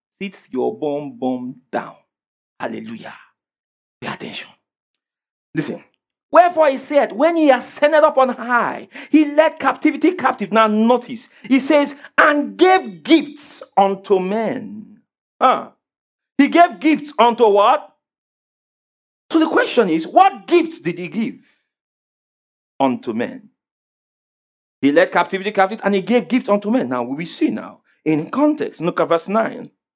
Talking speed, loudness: 135 wpm, -17 LUFS